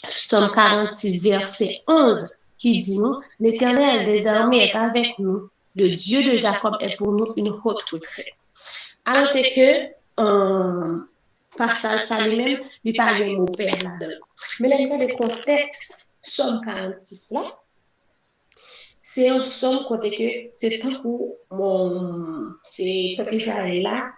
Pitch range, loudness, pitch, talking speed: 195-255 Hz, -20 LUFS, 220 Hz, 135 wpm